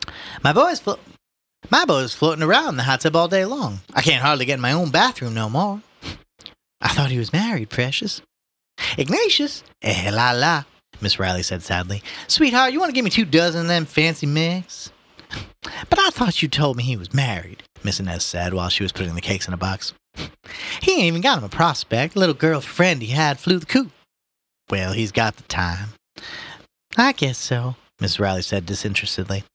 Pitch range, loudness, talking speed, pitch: 100-170 Hz, -20 LUFS, 195 wpm, 135 Hz